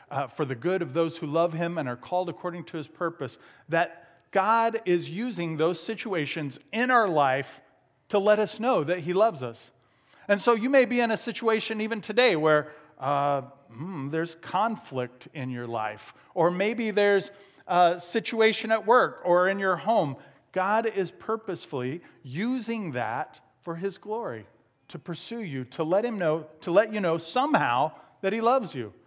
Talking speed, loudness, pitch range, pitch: 180 wpm, -27 LUFS, 150-220 Hz, 175 Hz